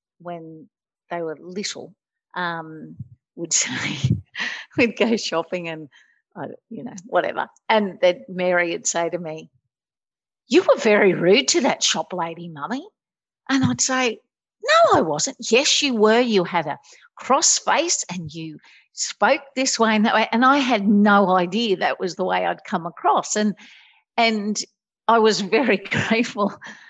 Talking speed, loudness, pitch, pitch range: 160 wpm, -20 LUFS, 210 Hz, 175-245 Hz